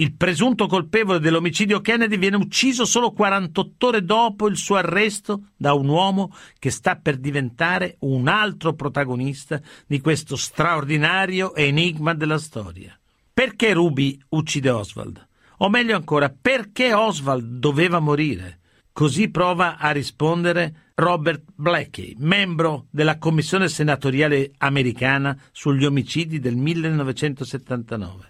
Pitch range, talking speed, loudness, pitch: 140-190 Hz, 120 wpm, -20 LUFS, 160 Hz